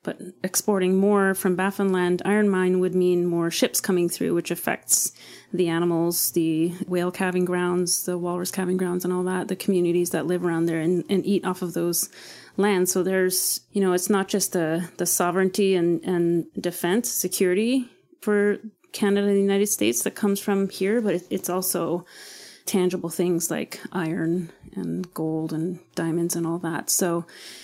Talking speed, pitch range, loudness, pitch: 180 wpm, 175-190 Hz, -23 LUFS, 180 Hz